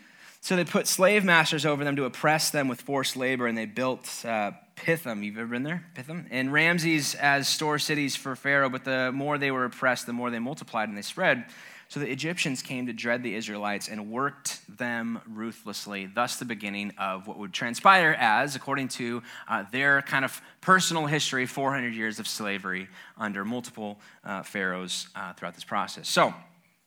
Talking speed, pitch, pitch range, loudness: 190 wpm, 130 Hz, 115-145 Hz, -27 LUFS